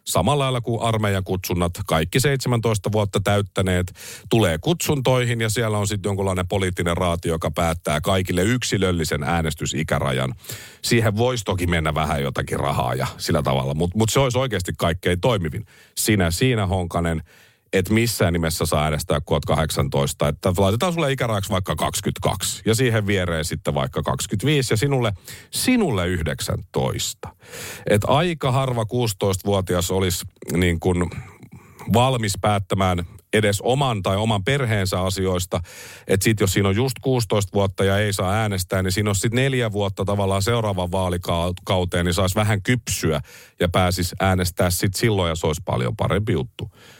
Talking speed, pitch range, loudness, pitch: 150 wpm, 90-115 Hz, -21 LUFS, 100 Hz